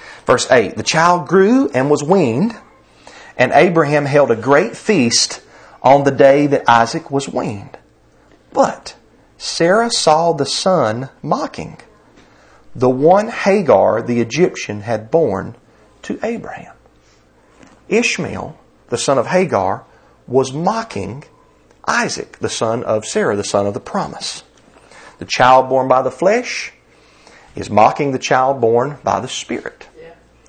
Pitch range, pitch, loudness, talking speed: 120-160 Hz, 135 Hz, -15 LUFS, 130 wpm